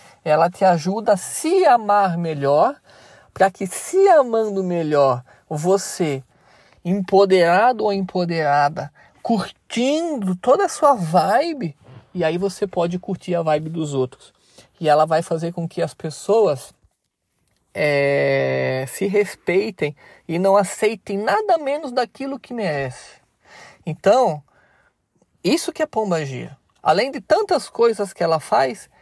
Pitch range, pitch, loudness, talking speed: 155-215 Hz, 185 Hz, -19 LUFS, 125 wpm